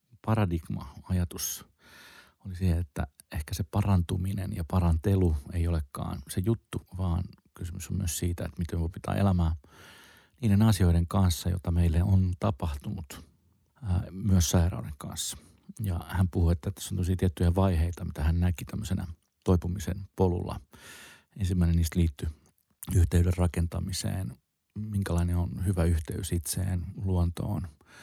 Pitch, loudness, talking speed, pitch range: 90 Hz, -29 LUFS, 130 wpm, 85-95 Hz